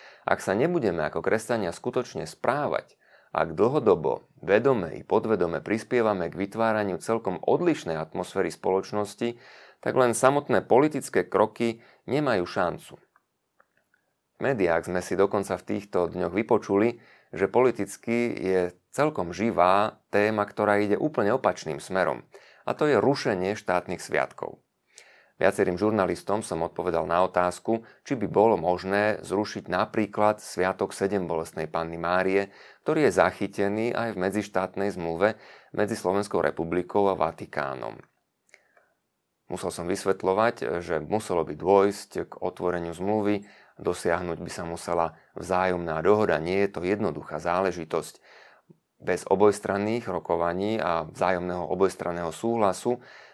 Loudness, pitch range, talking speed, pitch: -26 LUFS, 90-105 Hz, 125 wpm, 95 Hz